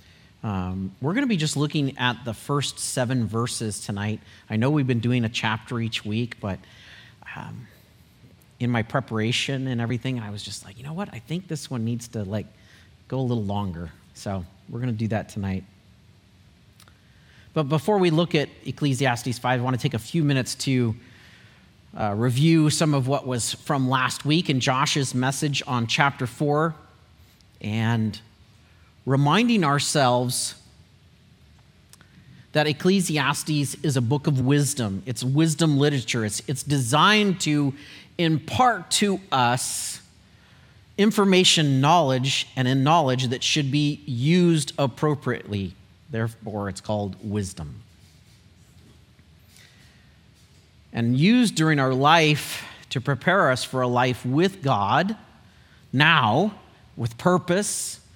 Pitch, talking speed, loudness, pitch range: 125 Hz, 140 wpm, -23 LUFS, 110-150 Hz